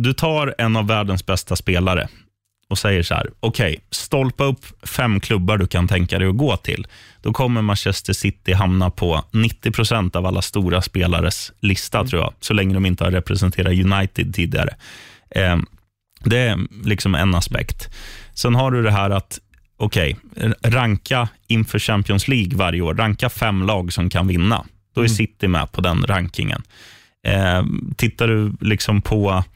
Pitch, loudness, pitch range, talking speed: 100 Hz, -19 LUFS, 95-115 Hz, 165 wpm